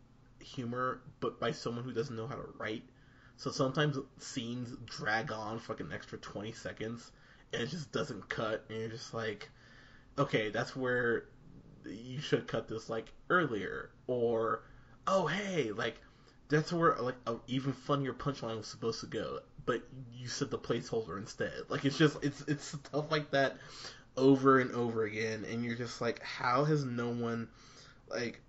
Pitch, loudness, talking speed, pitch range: 125 Hz, -35 LUFS, 170 wpm, 115-140 Hz